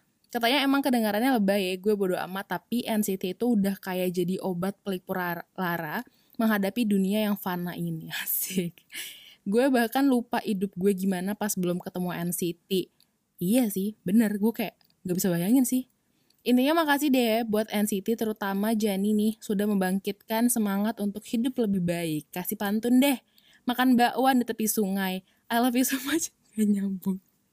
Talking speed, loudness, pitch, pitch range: 160 wpm, -27 LUFS, 210 Hz, 190-235 Hz